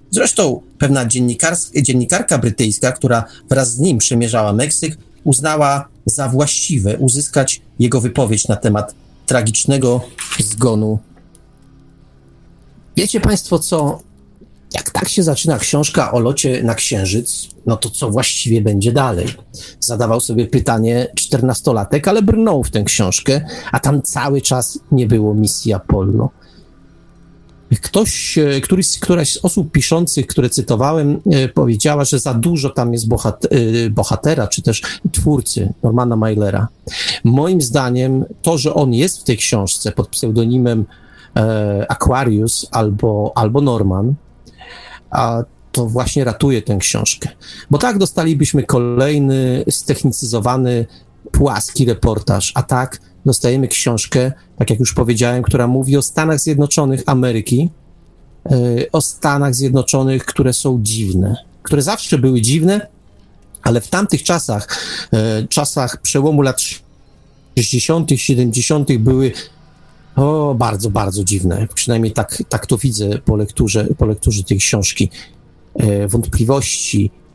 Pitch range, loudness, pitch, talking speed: 110-140 Hz, -15 LUFS, 125 Hz, 120 wpm